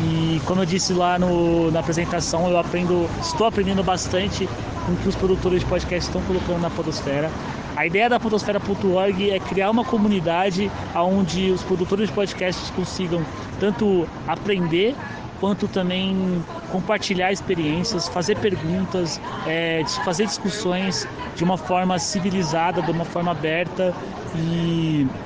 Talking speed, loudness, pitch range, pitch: 140 wpm, -22 LUFS, 170-195 Hz, 180 Hz